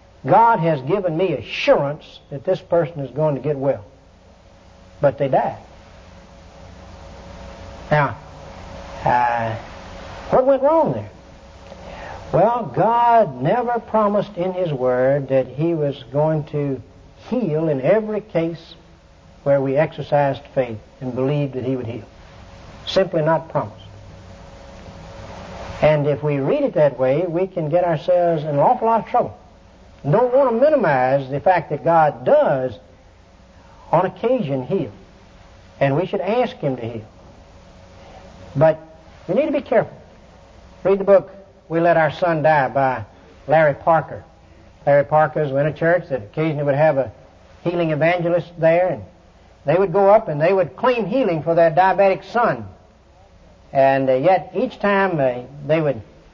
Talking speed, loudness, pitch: 145 wpm, -19 LUFS, 145 Hz